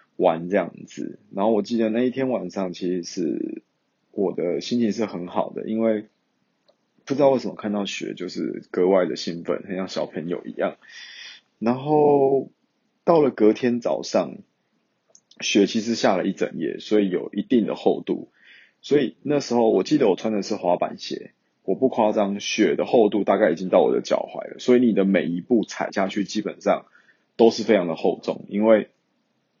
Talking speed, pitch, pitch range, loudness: 260 characters per minute, 110 Hz, 100-125 Hz, -22 LUFS